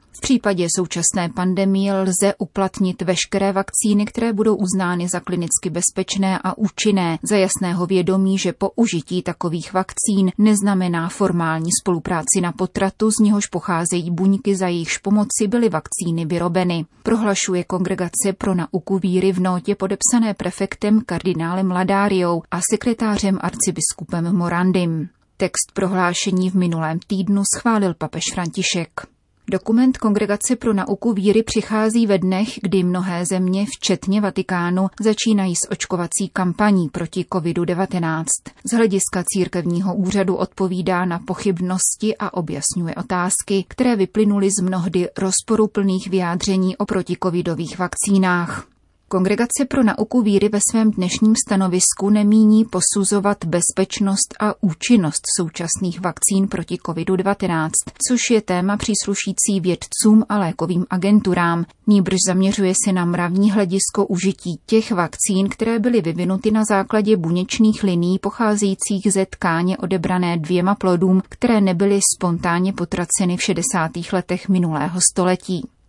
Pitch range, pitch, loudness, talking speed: 180-205 Hz, 190 Hz, -18 LUFS, 125 wpm